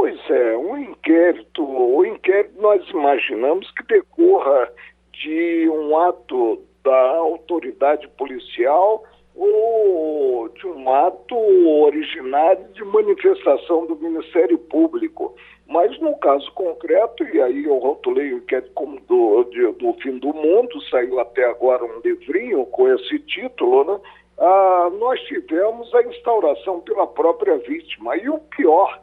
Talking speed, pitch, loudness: 135 wpm, 340 Hz, -18 LUFS